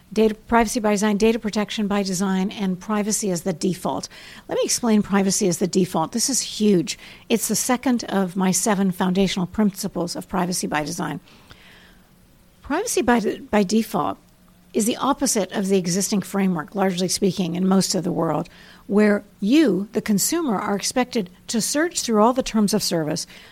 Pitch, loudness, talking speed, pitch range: 200 Hz, -21 LUFS, 175 wpm, 185-220 Hz